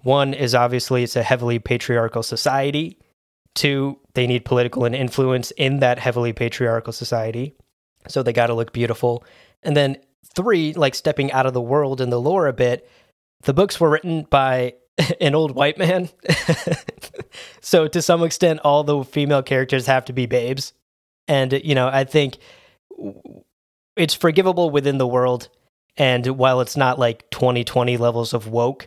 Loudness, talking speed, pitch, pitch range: -19 LUFS, 165 wpm, 130 Hz, 120-145 Hz